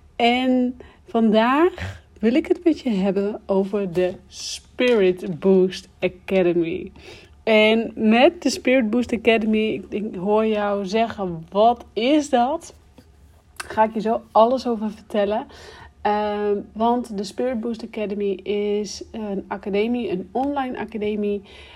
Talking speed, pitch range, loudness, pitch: 125 wpm, 205-240 Hz, -21 LUFS, 215 Hz